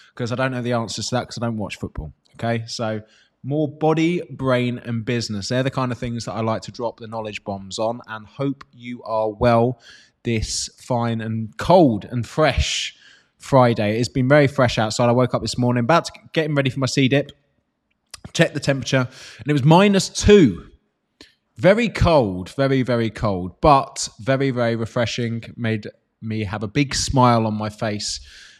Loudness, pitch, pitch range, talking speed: -20 LUFS, 120 Hz, 110-130 Hz, 185 wpm